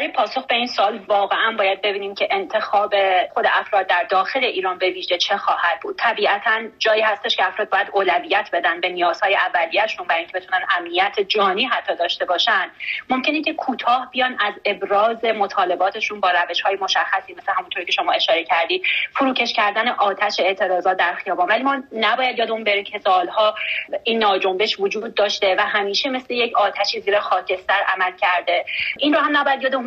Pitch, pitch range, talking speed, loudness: 210 Hz, 195-250 Hz, 175 wpm, -19 LUFS